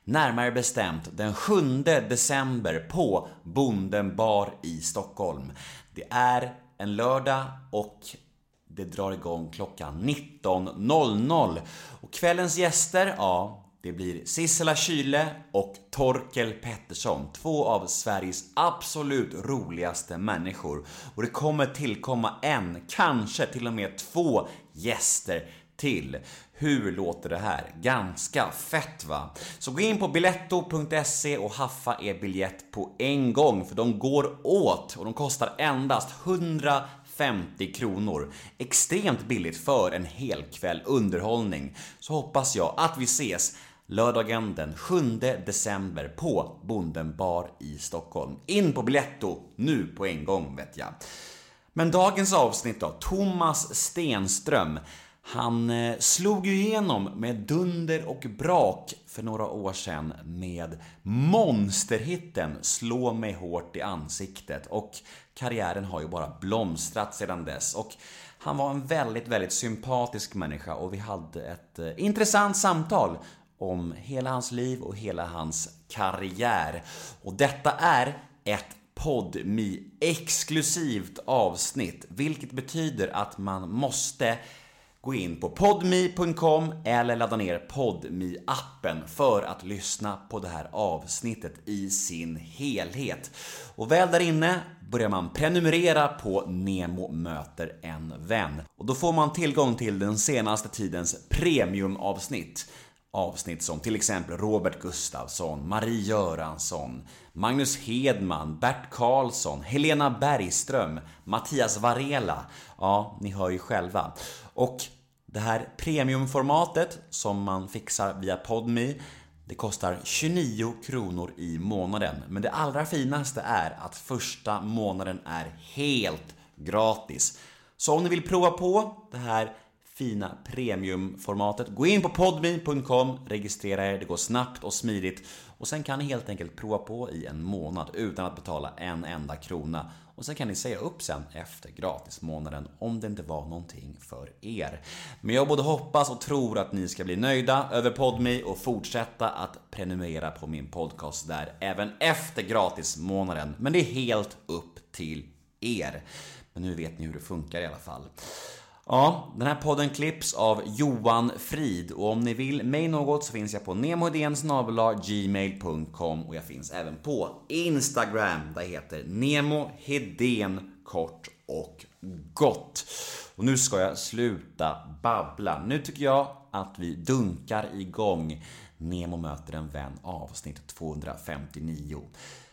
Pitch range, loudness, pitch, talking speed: 90-140 Hz, -28 LUFS, 110 Hz, 135 wpm